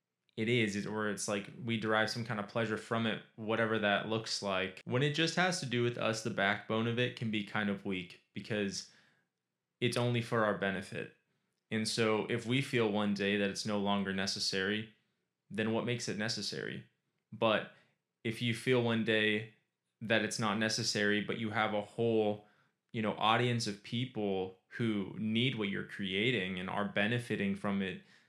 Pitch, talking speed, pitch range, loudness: 110 Hz, 185 wpm, 100-115 Hz, -34 LUFS